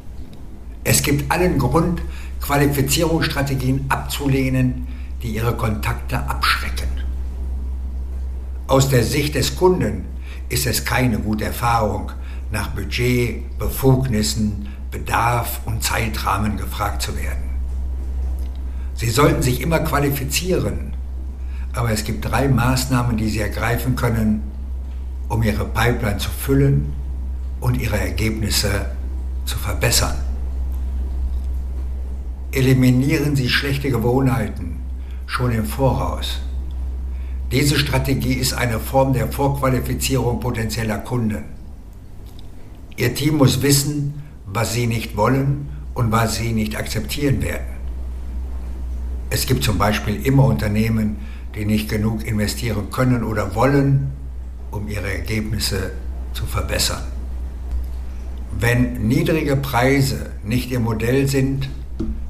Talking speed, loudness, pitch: 105 wpm, -20 LUFS, 105 Hz